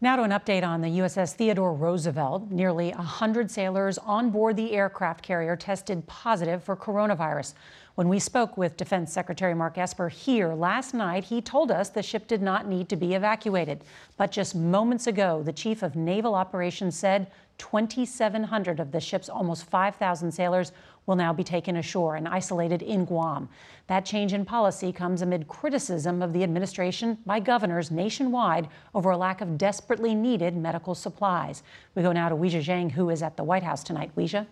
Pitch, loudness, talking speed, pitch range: 185 Hz, -27 LUFS, 180 wpm, 175-210 Hz